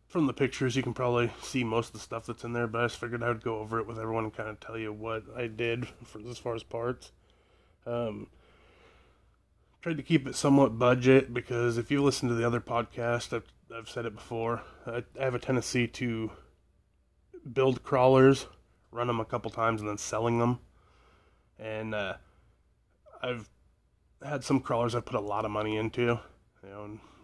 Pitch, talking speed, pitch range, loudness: 120 Hz, 200 wpm, 110-125 Hz, -30 LUFS